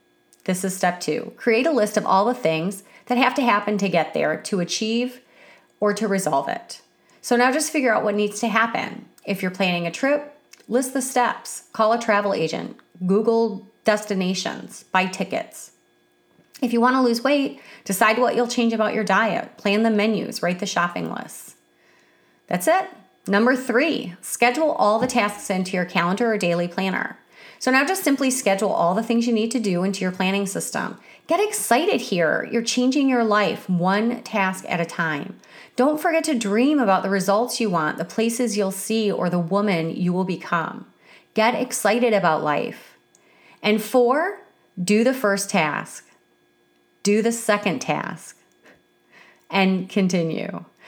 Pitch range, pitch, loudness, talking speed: 190-245 Hz, 215 Hz, -21 LUFS, 170 wpm